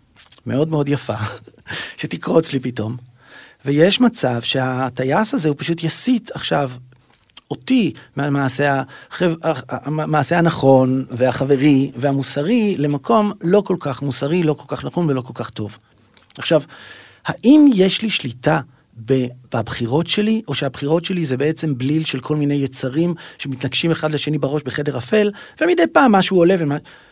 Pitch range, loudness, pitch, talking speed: 130-170 Hz, -18 LUFS, 145 Hz, 135 wpm